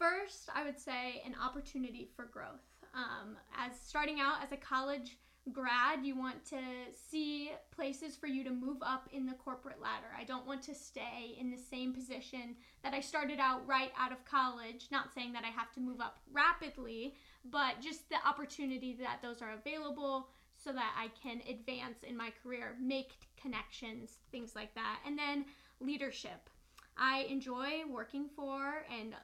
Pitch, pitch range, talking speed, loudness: 265 Hz, 250-285 Hz, 175 wpm, -40 LUFS